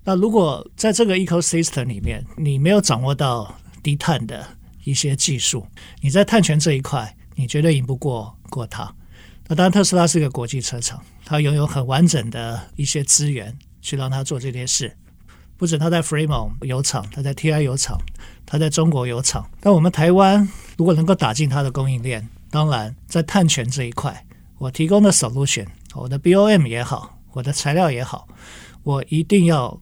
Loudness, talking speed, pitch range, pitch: -19 LUFS, 310 characters per minute, 125-165 Hz, 140 Hz